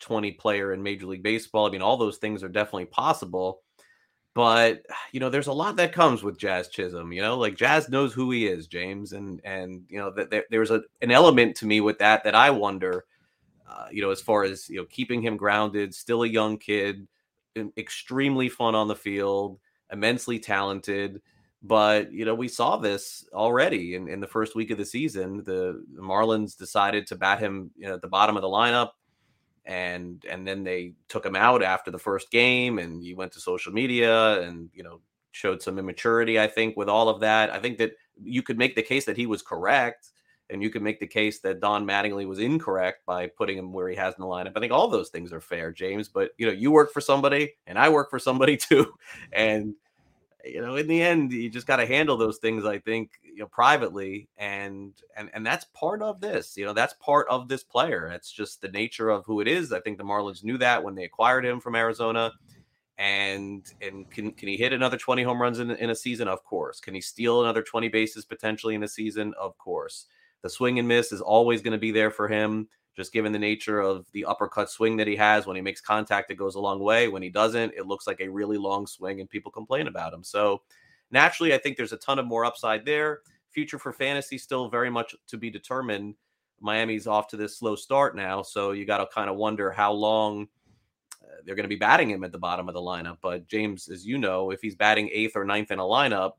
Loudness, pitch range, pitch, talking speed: -25 LUFS, 100-115 Hz, 105 Hz, 235 wpm